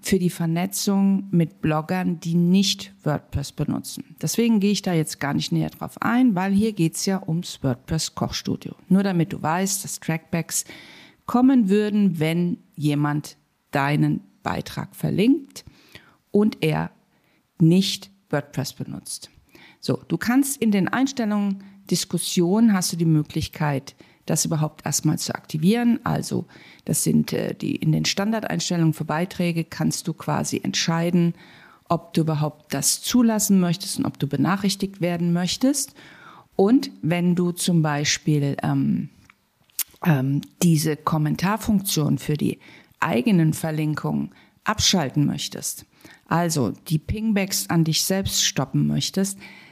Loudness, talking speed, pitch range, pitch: -22 LUFS, 130 wpm, 155-195 Hz, 175 Hz